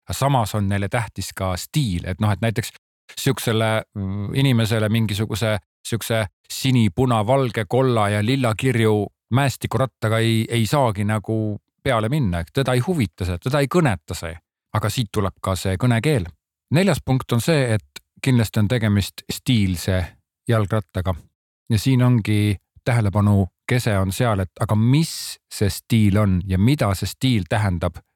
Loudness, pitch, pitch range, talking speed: -21 LUFS, 110 Hz, 100-125 Hz, 145 wpm